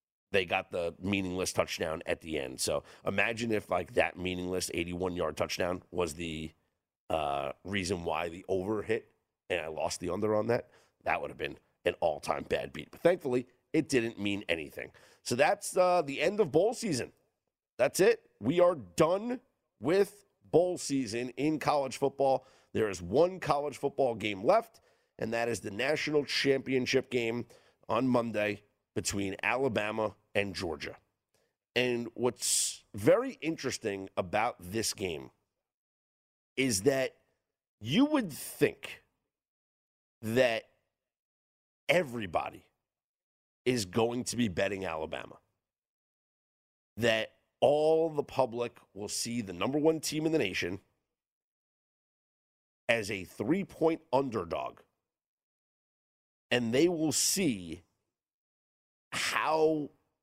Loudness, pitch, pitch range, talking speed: -31 LUFS, 120 Hz, 100-150 Hz, 125 wpm